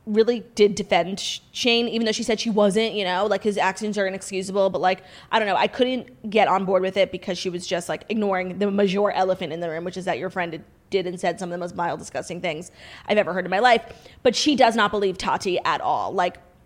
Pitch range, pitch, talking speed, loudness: 185-215 Hz, 195 Hz, 255 wpm, -23 LUFS